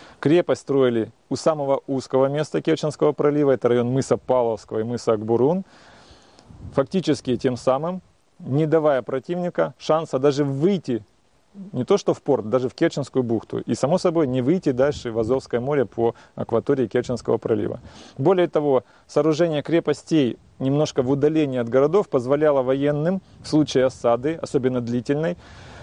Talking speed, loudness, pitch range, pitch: 145 wpm, -22 LUFS, 125-155 Hz, 135 Hz